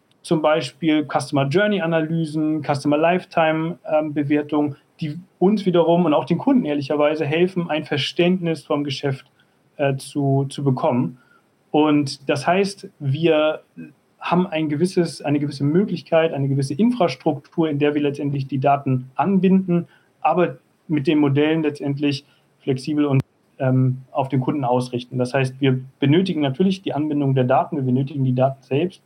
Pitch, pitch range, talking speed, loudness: 150 Hz, 140-165 Hz, 145 wpm, -20 LUFS